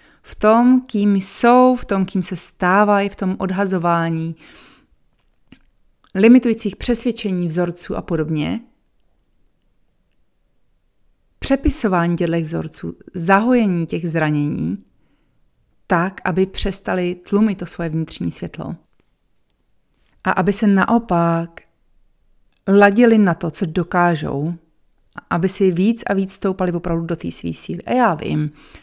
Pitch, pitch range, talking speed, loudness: 185 Hz, 170-205 Hz, 110 wpm, -18 LUFS